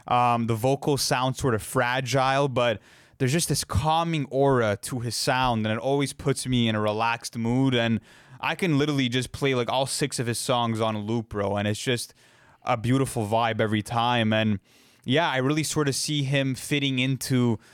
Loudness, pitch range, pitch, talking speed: -25 LUFS, 115-135 Hz, 125 Hz, 200 wpm